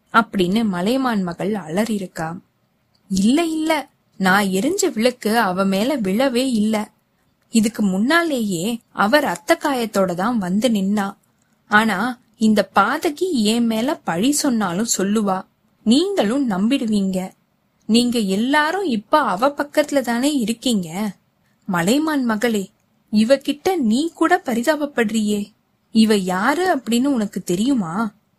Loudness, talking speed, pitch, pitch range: -19 LUFS, 100 wpm, 225 Hz, 200-275 Hz